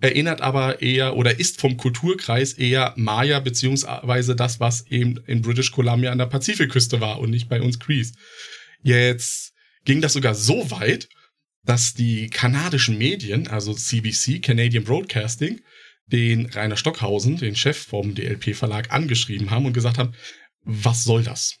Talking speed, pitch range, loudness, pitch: 150 wpm, 115-135 Hz, -21 LUFS, 125 Hz